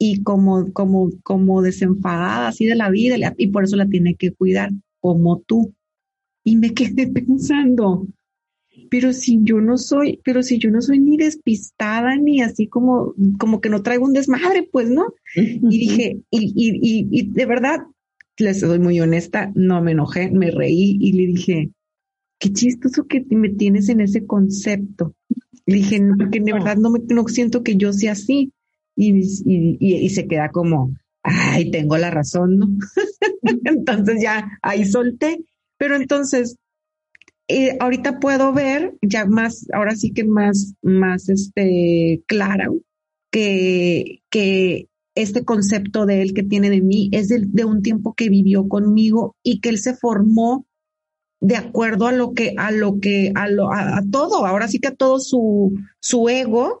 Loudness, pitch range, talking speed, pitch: -17 LUFS, 195-245 Hz, 170 wpm, 215 Hz